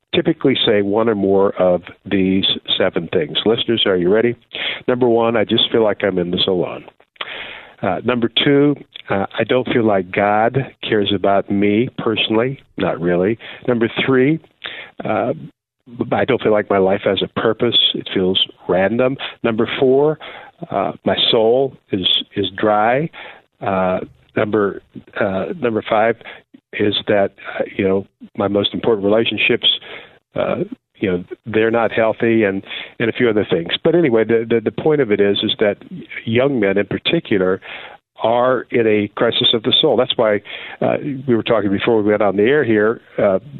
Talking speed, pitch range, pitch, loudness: 170 wpm, 100-125 Hz, 110 Hz, -17 LUFS